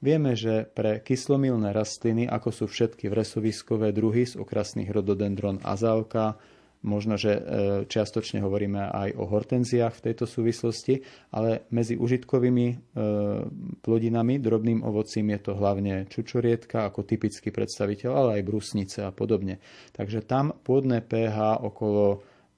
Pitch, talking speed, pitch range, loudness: 110 Hz, 125 wpm, 105-120 Hz, -27 LUFS